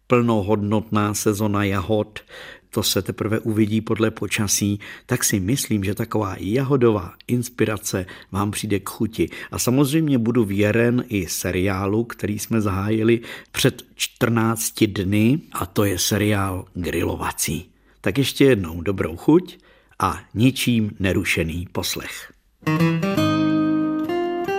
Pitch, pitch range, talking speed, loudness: 110 Hz, 100-120 Hz, 110 wpm, -21 LUFS